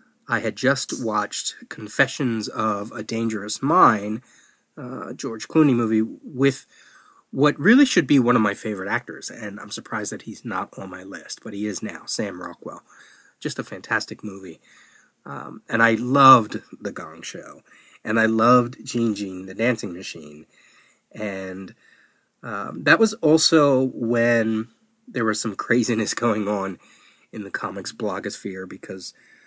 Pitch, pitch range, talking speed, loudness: 115 Hz, 105-130 Hz, 155 wpm, -22 LUFS